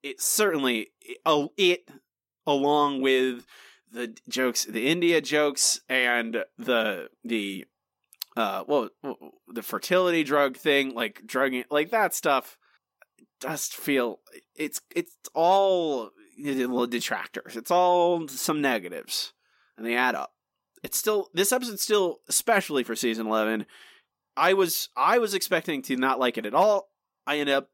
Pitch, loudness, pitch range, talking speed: 145 Hz, -25 LUFS, 125-185 Hz, 135 wpm